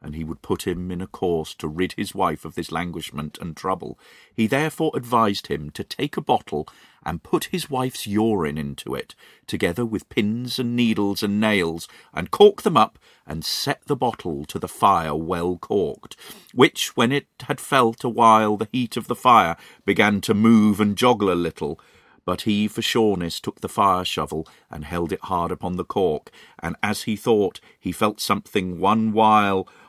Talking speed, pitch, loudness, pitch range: 190 wpm, 105 Hz, -22 LUFS, 85-115 Hz